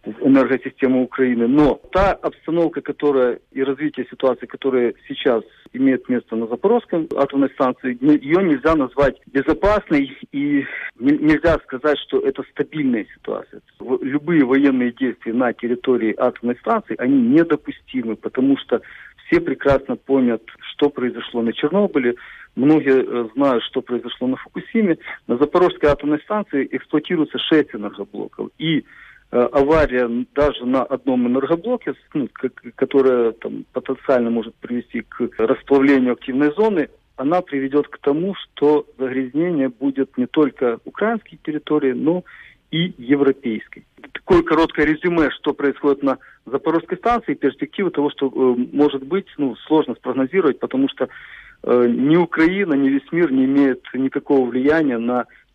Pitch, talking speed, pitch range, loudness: 140 Hz, 125 wpm, 130-165 Hz, -19 LUFS